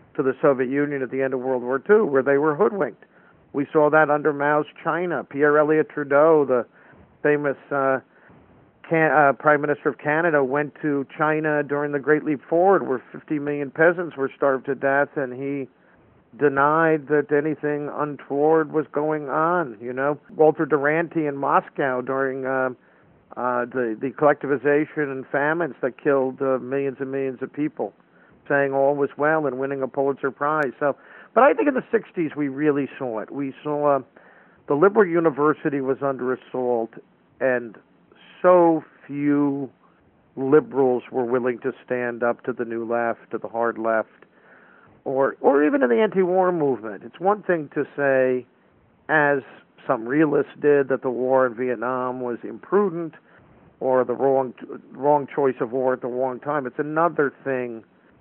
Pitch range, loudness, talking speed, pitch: 130-150 Hz, -22 LUFS, 170 wpm, 140 Hz